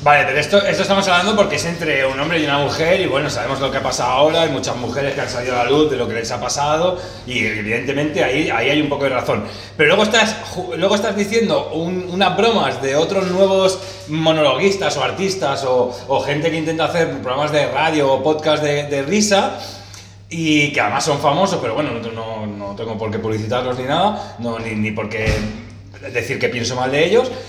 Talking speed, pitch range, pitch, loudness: 220 wpm, 120-175 Hz, 145 Hz, -17 LUFS